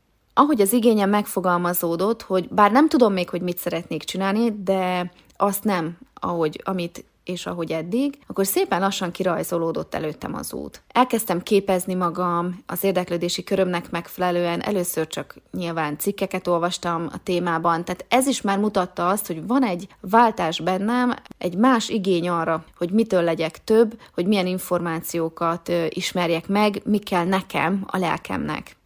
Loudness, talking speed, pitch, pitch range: -22 LUFS, 150 wpm, 180 Hz, 170-205 Hz